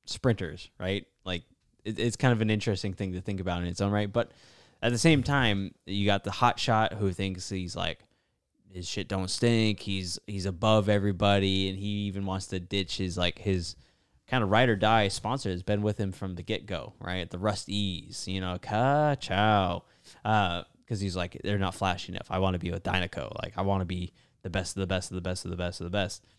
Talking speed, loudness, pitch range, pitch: 230 wpm, -29 LUFS, 95-110 Hz, 100 Hz